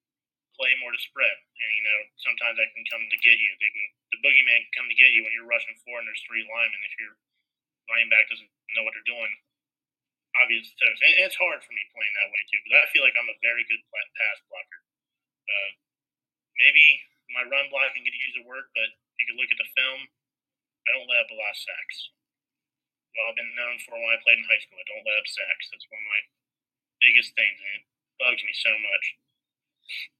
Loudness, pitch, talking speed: -22 LUFS, 140 Hz, 225 wpm